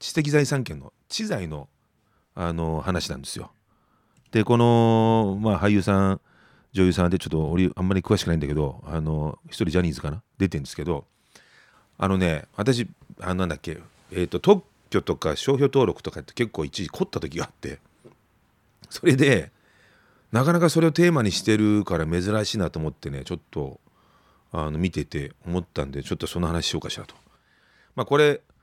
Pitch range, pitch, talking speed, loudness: 80-115 Hz, 95 Hz, 350 characters per minute, -24 LUFS